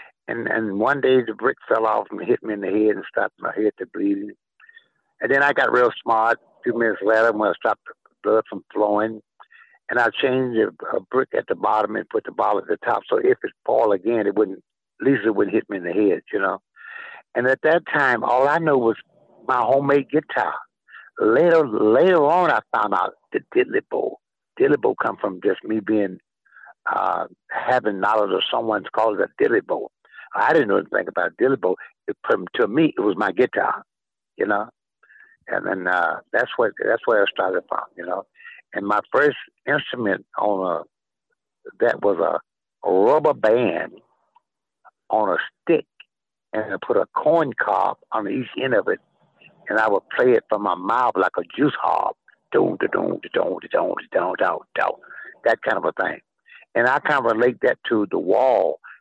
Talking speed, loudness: 200 wpm, -21 LUFS